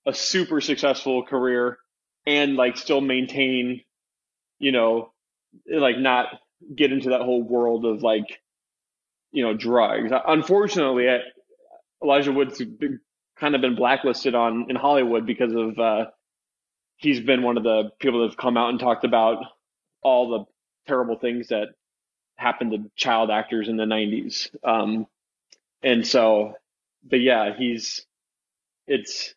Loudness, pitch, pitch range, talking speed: -22 LUFS, 125 Hz, 115-135 Hz, 140 wpm